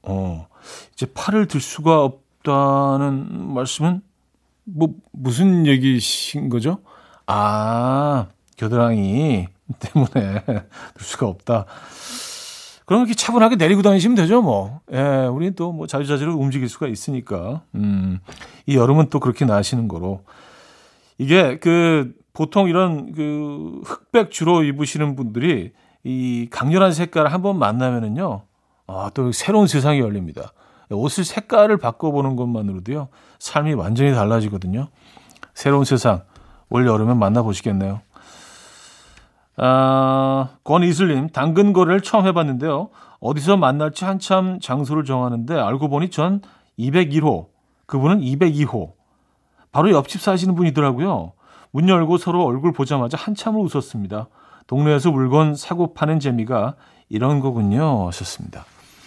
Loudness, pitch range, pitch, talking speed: -19 LUFS, 120-170 Hz, 140 Hz, 275 characters per minute